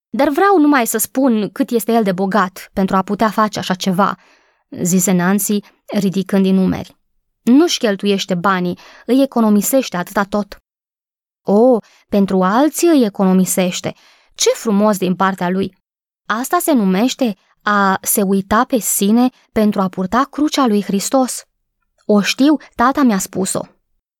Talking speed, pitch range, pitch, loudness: 140 wpm, 195-250 Hz, 210 Hz, -15 LUFS